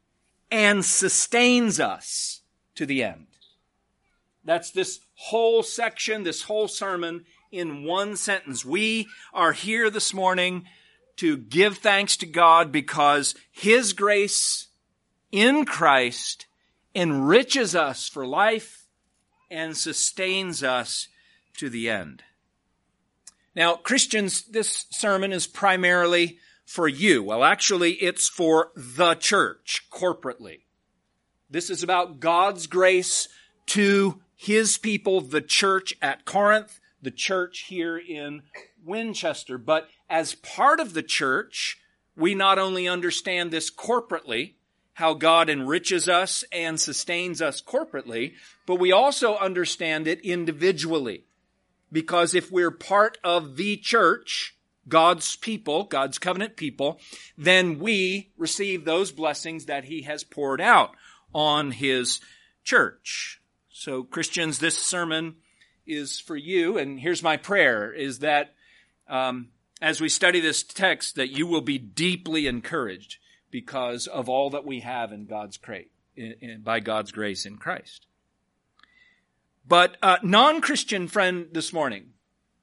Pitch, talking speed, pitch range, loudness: 175 Hz, 125 wpm, 155-200 Hz, -23 LUFS